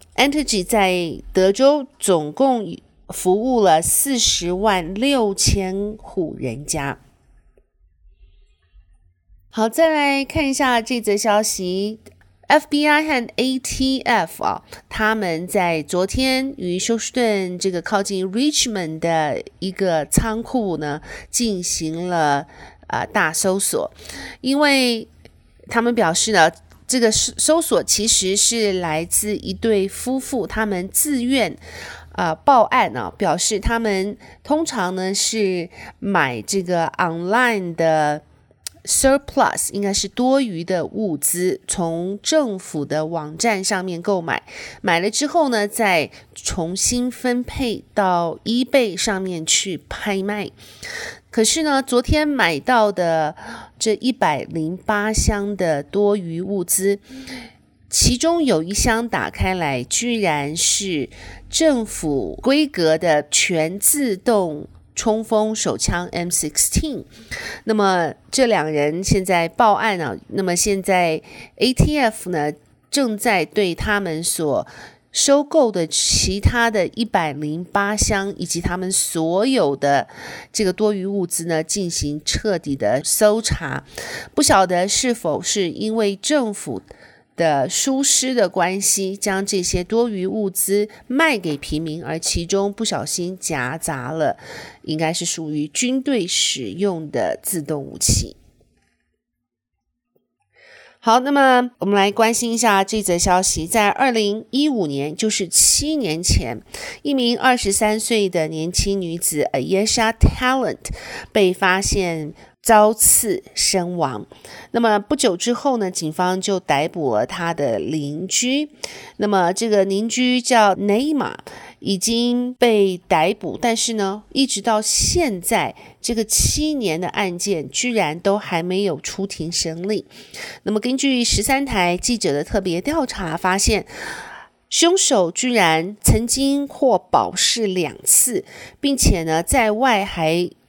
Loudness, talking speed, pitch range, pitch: -19 LUFS, 200 characters per minute, 175-235 Hz, 200 Hz